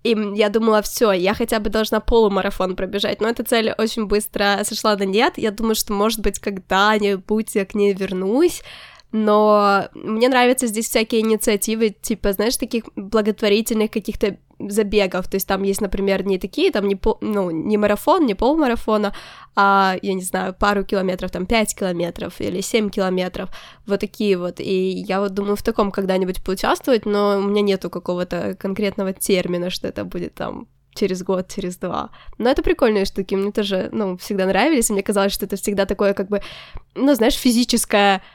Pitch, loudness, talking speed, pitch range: 205 Hz, -19 LUFS, 180 wpm, 195-220 Hz